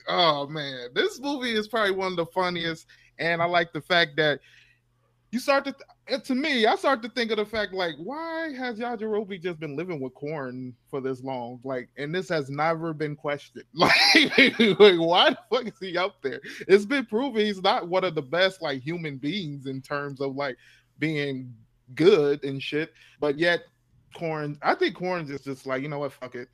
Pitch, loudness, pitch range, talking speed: 165 Hz, -25 LUFS, 140-210 Hz, 205 wpm